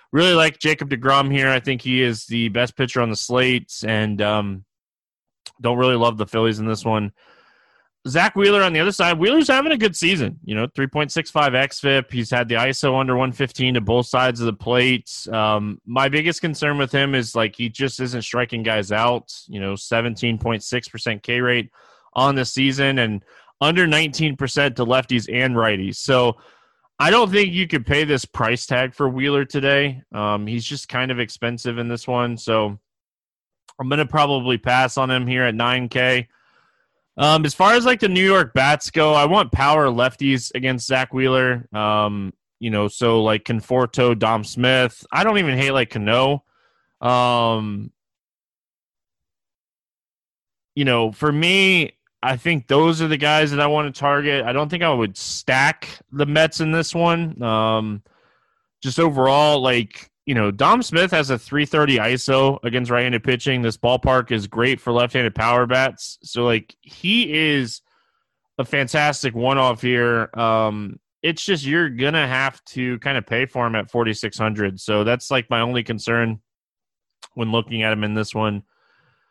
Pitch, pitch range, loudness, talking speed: 125 Hz, 115-145 Hz, -19 LUFS, 175 wpm